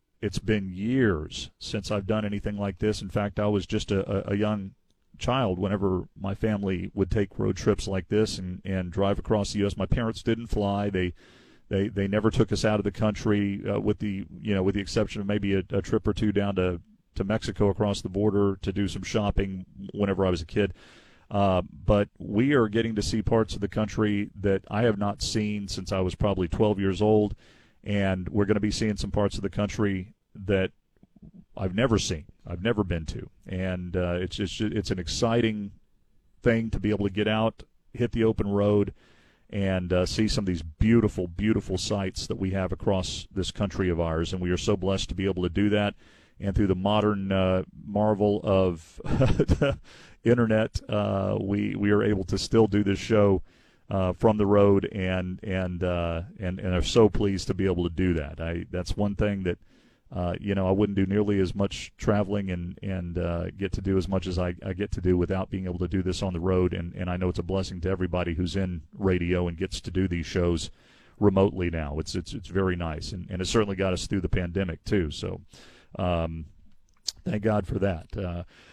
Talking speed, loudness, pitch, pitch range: 215 wpm, -27 LUFS, 100 Hz, 90-105 Hz